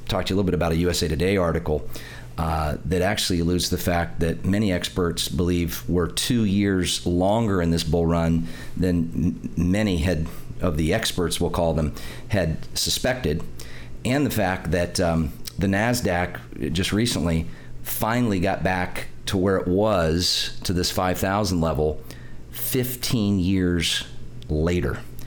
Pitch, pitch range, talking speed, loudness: 90 Hz, 80-95 Hz, 150 wpm, -23 LUFS